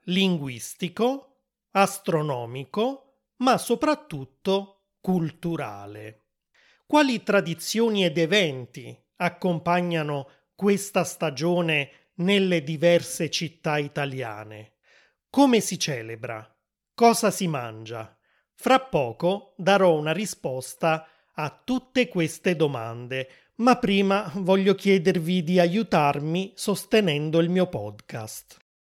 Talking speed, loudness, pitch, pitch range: 85 wpm, -24 LUFS, 175 Hz, 145-200 Hz